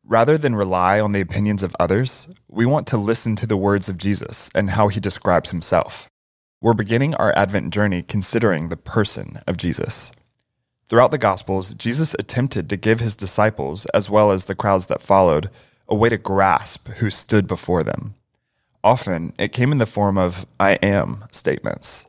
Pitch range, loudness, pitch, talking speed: 95-115 Hz, -20 LUFS, 105 Hz, 180 wpm